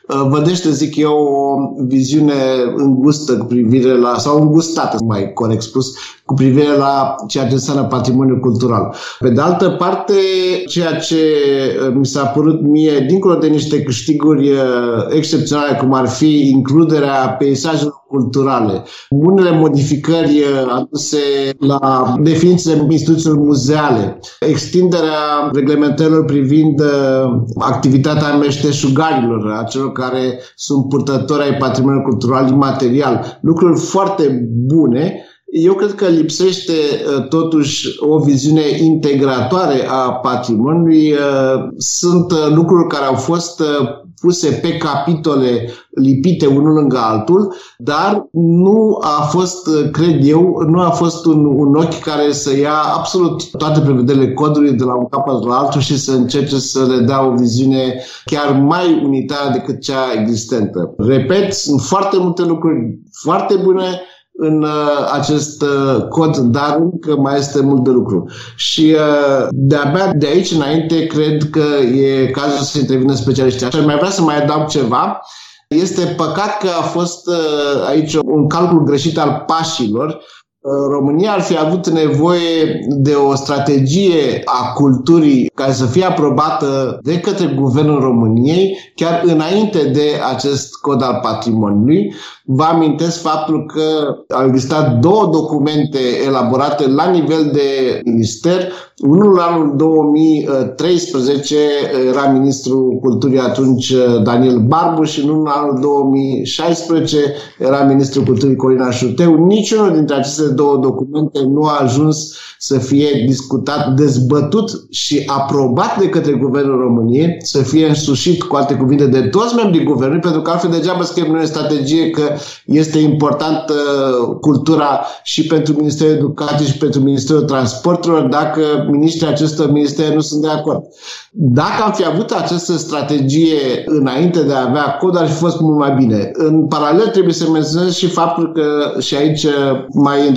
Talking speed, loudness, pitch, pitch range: 140 wpm, -13 LUFS, 145 Hz, 135-160 Hz